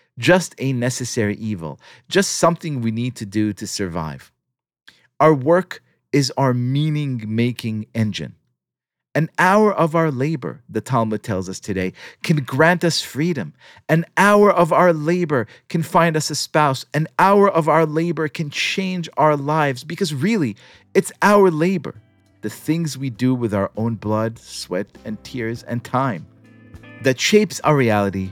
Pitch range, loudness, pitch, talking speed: 110-165 Hz, -19 LUFS, 135 Hz, 155 wpm